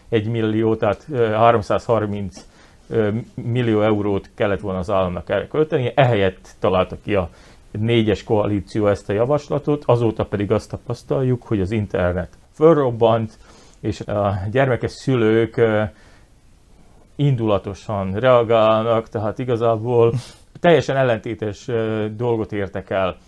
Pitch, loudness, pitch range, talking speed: 110 Hz, -20 LUFS, 100-120 Hz, 110 wpm